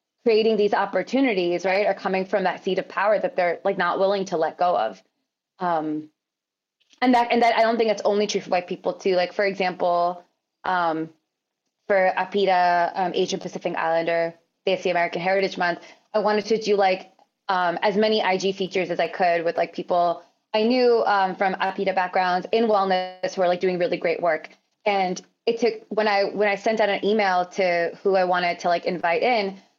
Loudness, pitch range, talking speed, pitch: -22 LUFS, 175-205 Hz, 200 wpm, 190 Hz